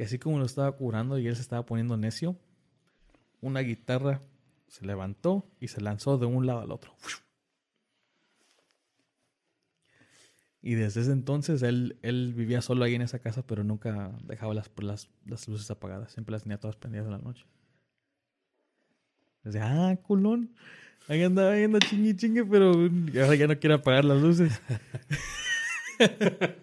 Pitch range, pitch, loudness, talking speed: 115-165 Hz, 130 Hz, -28 LUFS, 155 wpm